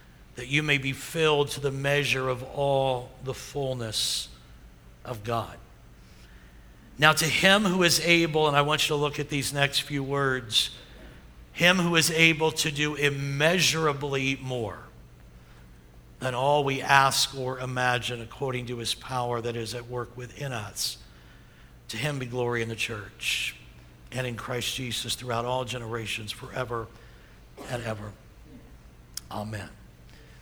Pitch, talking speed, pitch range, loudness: 125 Hz, 145 wpm, 105-140 Hz, -26 LUFS